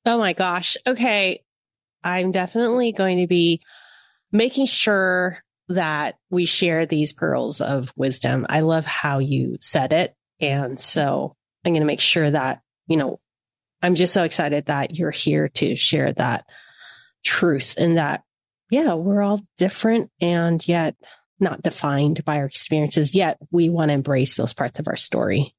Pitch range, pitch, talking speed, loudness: 140-185 Hz, 160 Hz, 160 wpm, -21 LUFS